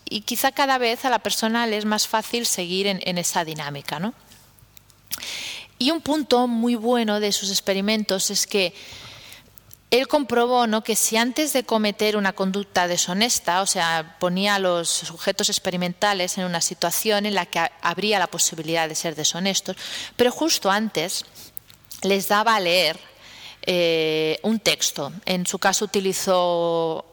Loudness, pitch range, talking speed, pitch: -22 LUFS, 175-225 Hz, 160 wpm, 195 Hz